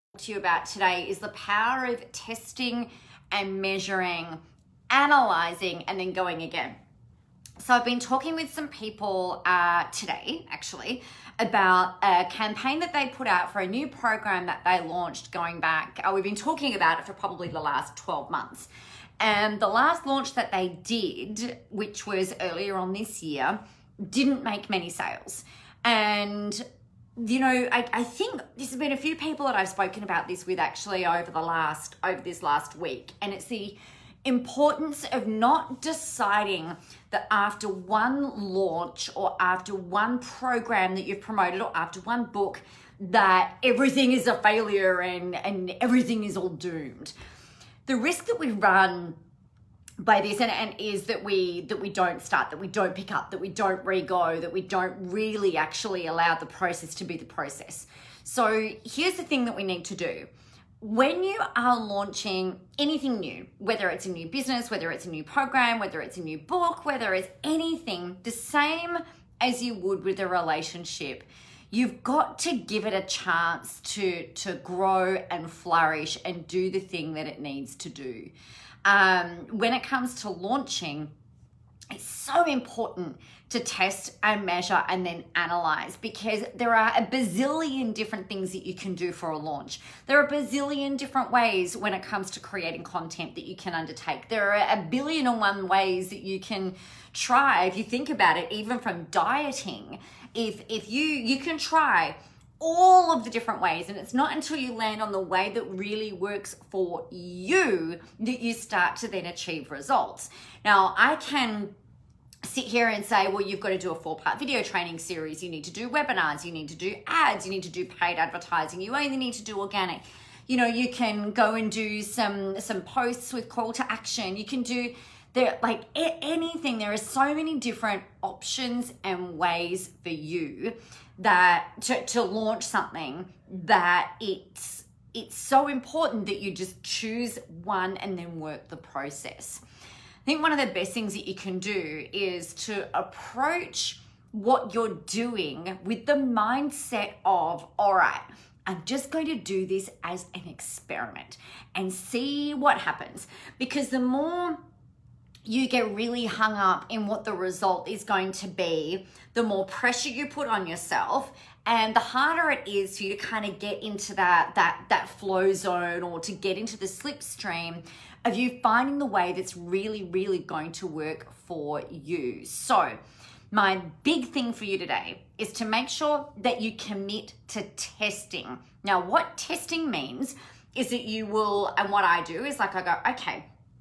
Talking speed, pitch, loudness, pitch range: 180 wpm, 205 Hz, -27 LUFS, 185-245 Hz